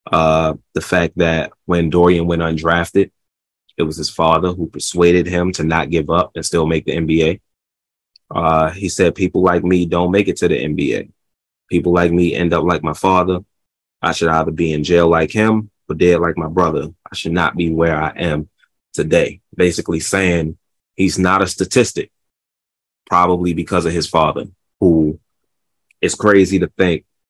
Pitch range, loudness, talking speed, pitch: 80-90 Hz, -16 LUFS, 180 wpm, 85 Hz